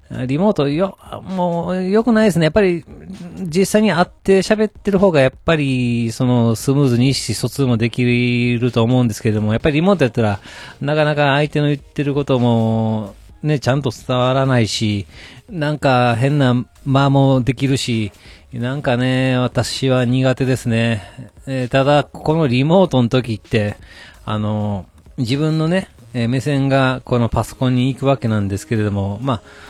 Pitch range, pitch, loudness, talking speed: 115-145 Hz, 130 Hz, -17 LUFS, 325 characters per minute